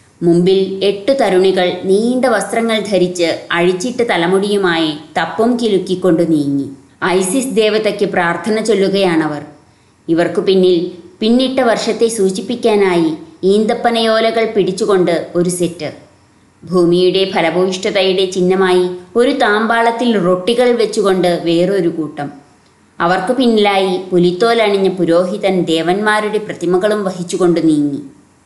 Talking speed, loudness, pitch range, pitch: 85 wpm, -14 LUFS, 170-215 Hz, 190 Hz